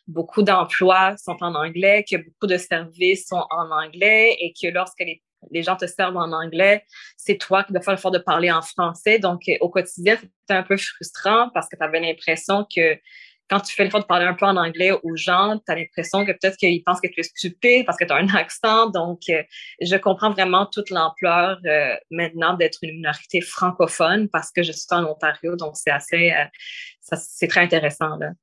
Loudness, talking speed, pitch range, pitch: -20 LUFS, 210 wpm, 165-195 Hz, 180 Hz